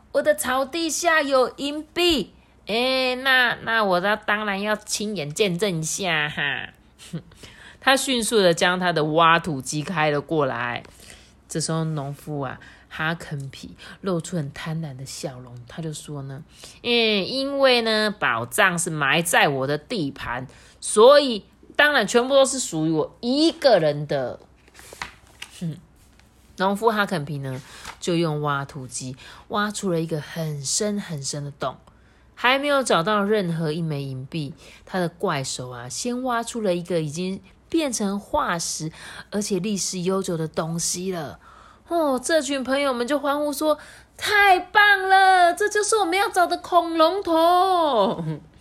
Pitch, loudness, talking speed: 190 Hz, -22 LUFS, 210 characters per minute